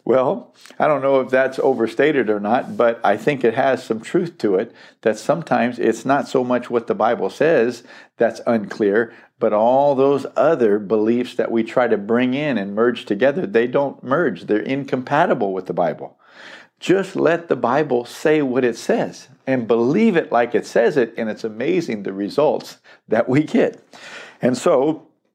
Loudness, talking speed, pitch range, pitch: -19 LUFS, 180 wpm, 115-135 Hz, 125 Hz